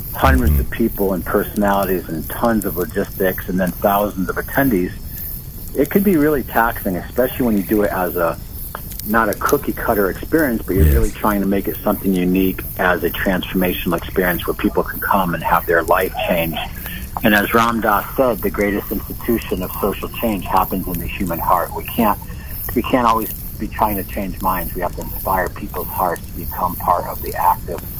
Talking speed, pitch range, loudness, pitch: 195 wpm, 90-105 Hz, -18 LUFS, 95 Hz